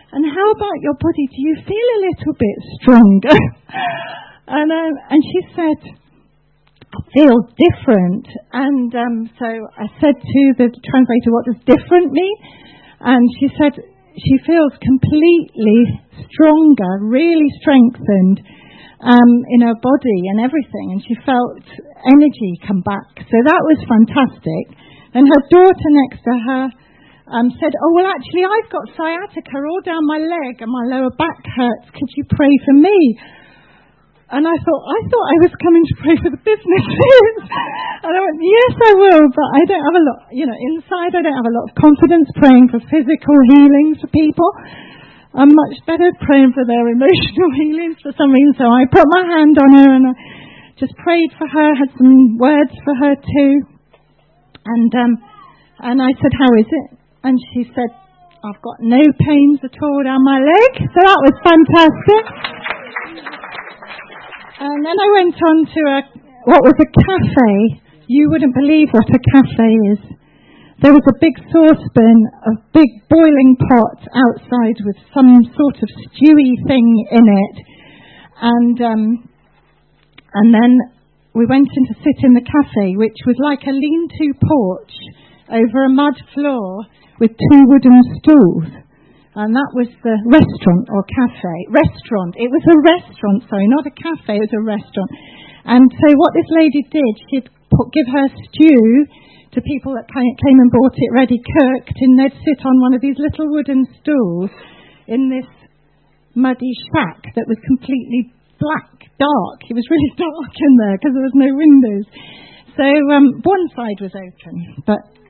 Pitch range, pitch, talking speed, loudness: 235-310 Hz, 270 Hz, 165 wpm, -12 LUFS